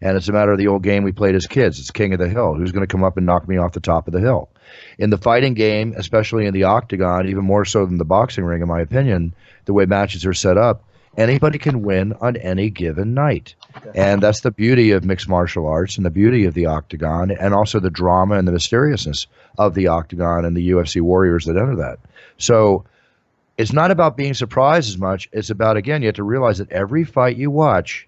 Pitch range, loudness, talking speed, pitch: 90-110 Hz, -17 LUFS, 240 wpm, 100 Hz